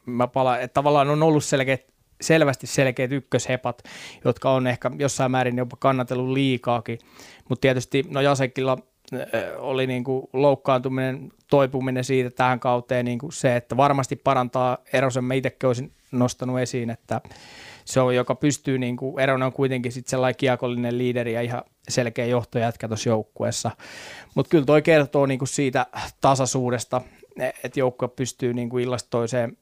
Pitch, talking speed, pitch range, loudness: 130 Hz, 140 wpm, 125-135 Hz, -23 LUFS